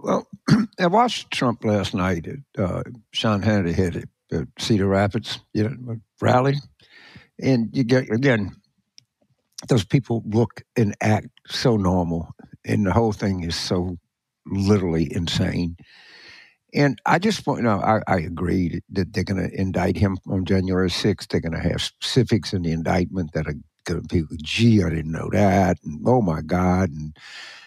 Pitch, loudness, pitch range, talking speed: 100 Hz, -22 LUFS, 90-115 Hz, 165 wpm